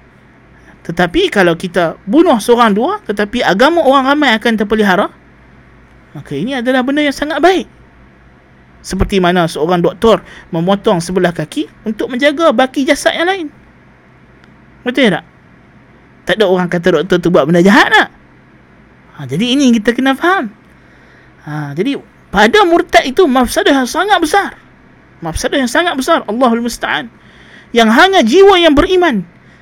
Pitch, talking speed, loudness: 235 Hz, 140 wpm, -11 LUFS